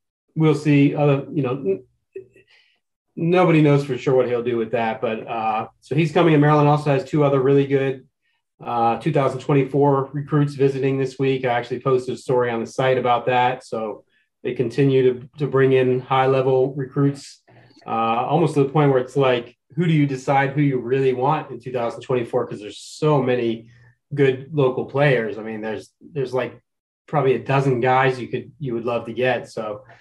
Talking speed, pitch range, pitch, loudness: 190 wpm, 125-145 Hz, 135 Hz, -20 LUFS